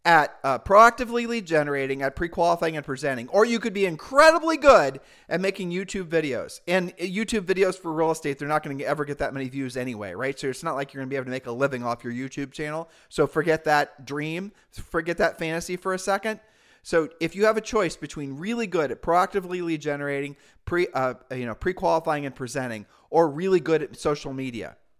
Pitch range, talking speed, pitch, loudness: 140-185 Hz, 210 wpm, 160 Hz, -24 LUFS